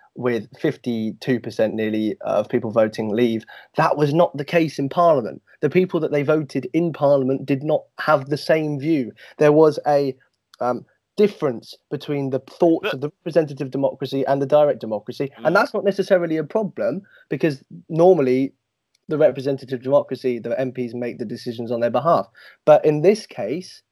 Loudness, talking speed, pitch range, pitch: -21 LUFS, 165 wpm, 125-160 Hz, 145 Hz